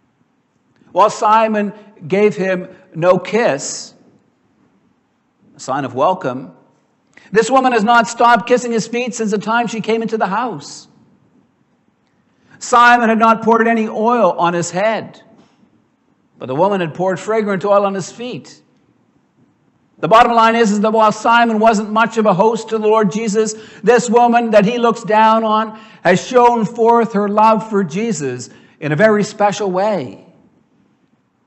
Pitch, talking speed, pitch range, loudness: 220 Hz, 155 wpm, 200-230 Hz, -14 LUFS